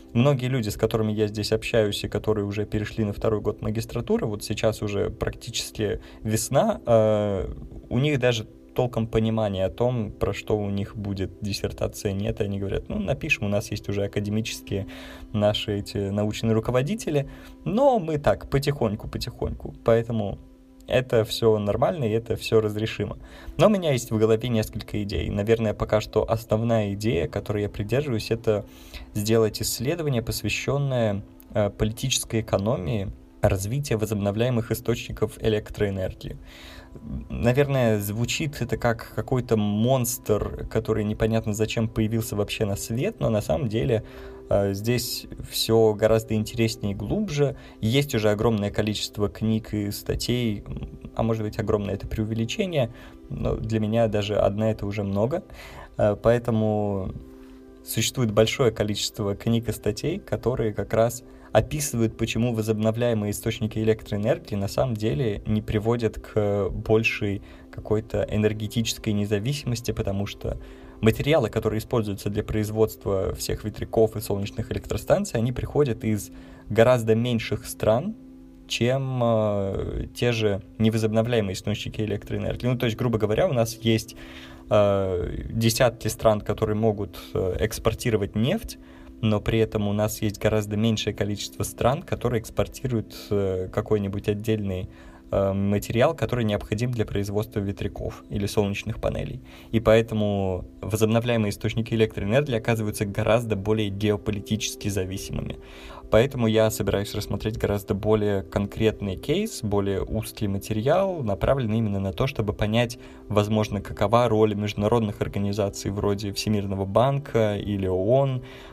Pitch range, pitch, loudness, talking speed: 105-115 Hz, 110 Hz, -25 LUFS, 130 wpm